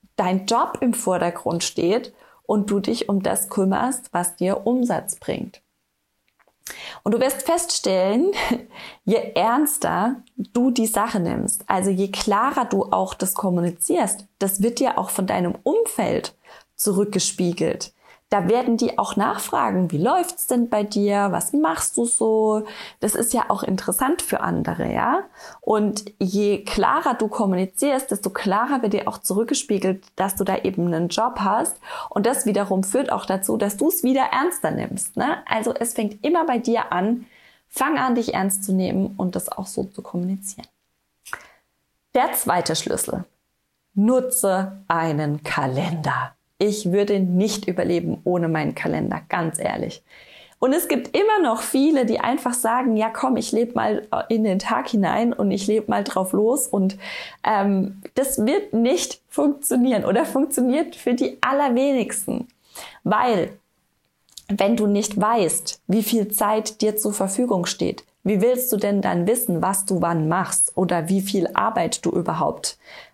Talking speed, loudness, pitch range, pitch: 155 wpm, -22 LUFS, 195-250 Hz, 215 Hz